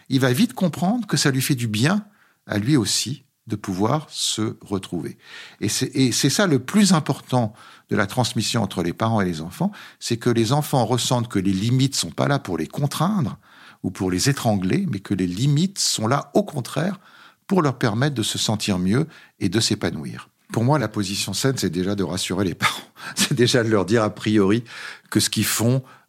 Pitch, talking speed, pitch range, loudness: 120 Hz, 210 wpm, 100-145 Hz, -22 LUFS